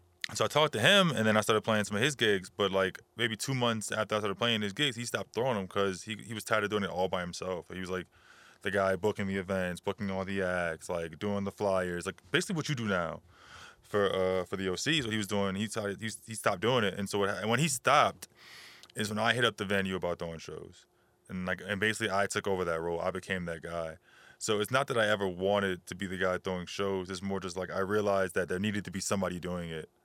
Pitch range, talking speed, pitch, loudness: 95-110 Hz, 270 wpm, 100 Hz, -31 LUFS